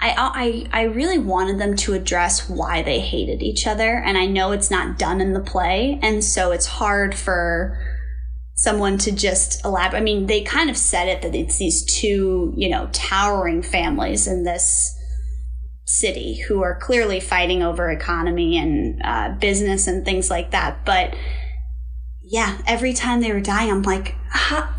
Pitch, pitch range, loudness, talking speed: 190 Hz, 170-215 Hz, -20 LUFS, 175 wpm